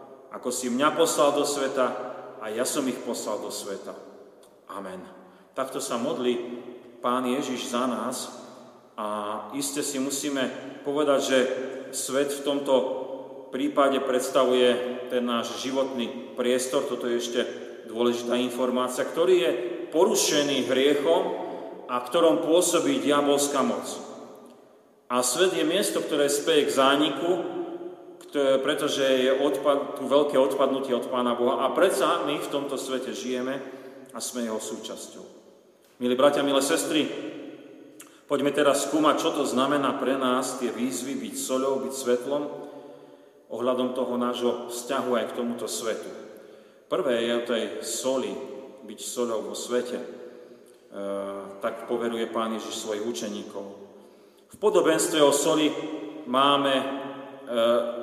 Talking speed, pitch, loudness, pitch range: 130 wpm, 130 Hz, -26 LUFS, 120-140 Hz